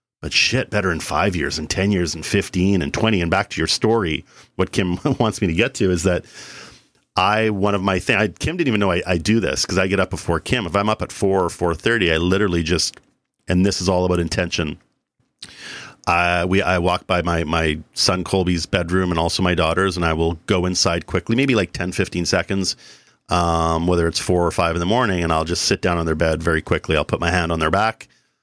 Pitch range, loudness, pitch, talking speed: 85-100 Hz, -19 LUFS, 90 Hz, 240 wpm